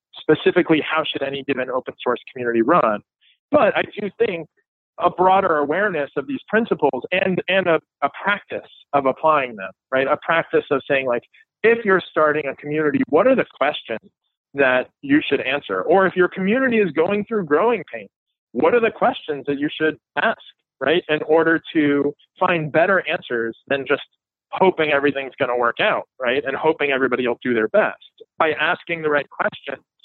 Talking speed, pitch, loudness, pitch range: 180 wpm, 155 Hz, -20 LUFS, 140-190 Hz